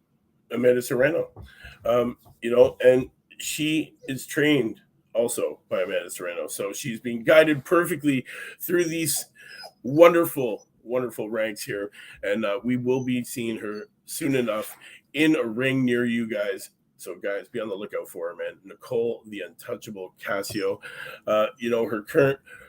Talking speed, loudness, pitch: 150 wpm, -25 LUFS, 135 Hz